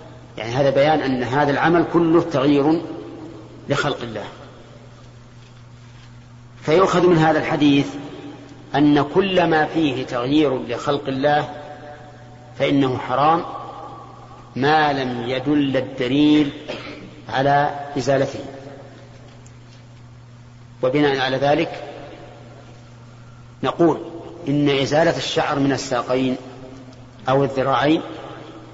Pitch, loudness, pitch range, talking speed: 135 Hz, -19 LUFS, 120-150 Hz, 85 wpm